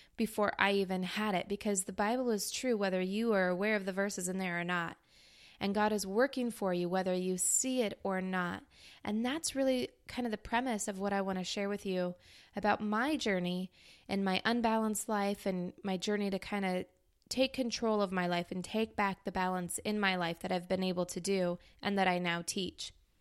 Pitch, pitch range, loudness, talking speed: 195 Hz, 185-215 Hz, -34 LUFS, 220 wpm